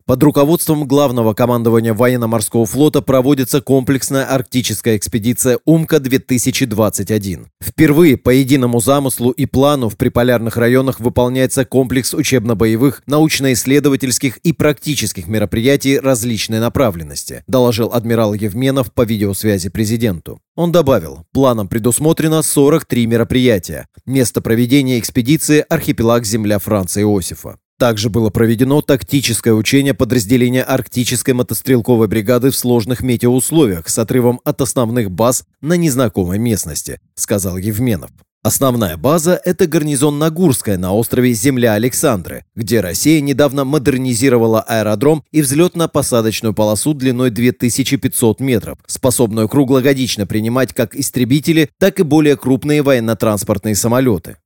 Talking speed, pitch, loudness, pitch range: 110 wpm, 125 Hz, -14 LUFS, 115-140 Hz